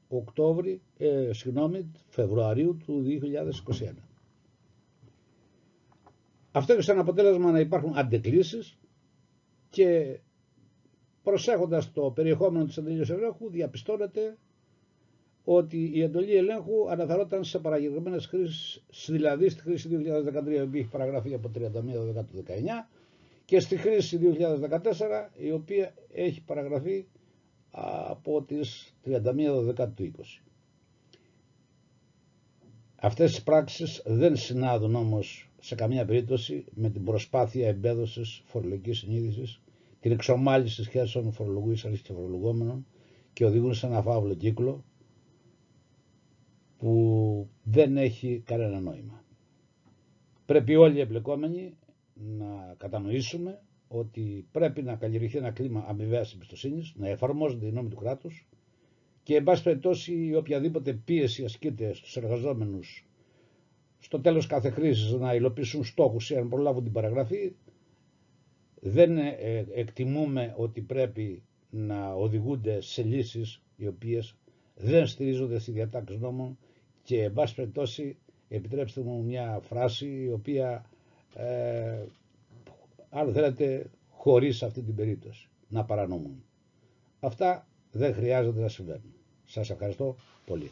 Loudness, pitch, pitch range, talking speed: -29 LUFS, 130 Hz, 115-155 Hz, 110 wpm